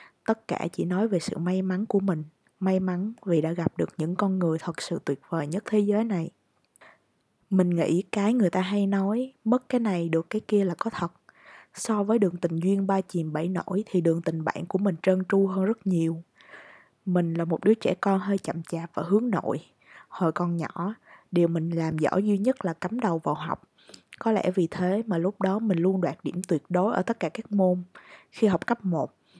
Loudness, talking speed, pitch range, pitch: -27 LUFS, 225 wpm, 170-205 Hz, 185 Hz